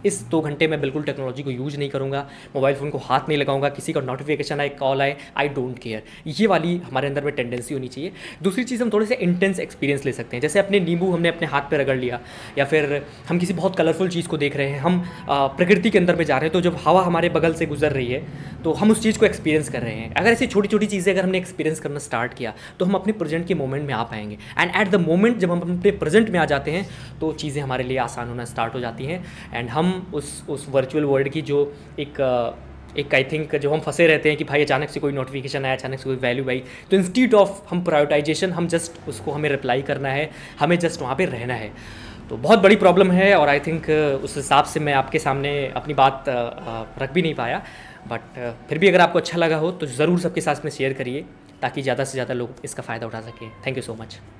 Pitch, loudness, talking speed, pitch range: 145 Hz, -21 LUFS, 250 wpm, 130-170 Hz